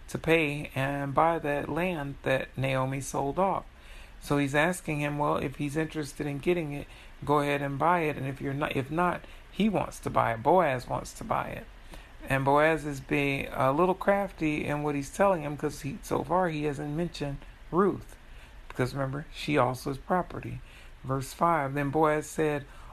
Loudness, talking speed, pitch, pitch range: -29 LUFS, 190 wpm, 145 Hz, 140-160 Hz